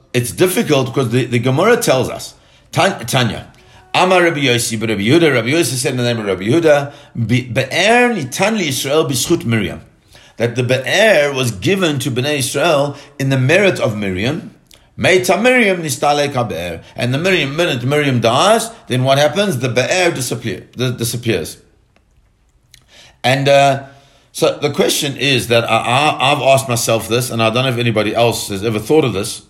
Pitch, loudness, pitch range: 130 Hz, -14 LUFS, 115-150 Hz